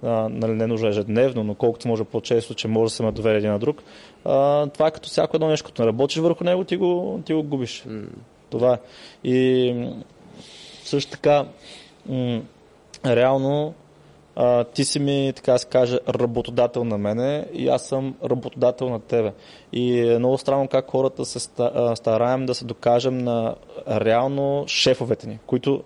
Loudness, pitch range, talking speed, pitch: -22 LUFS, 115-140 Hz, 155 wpm, 125 Hz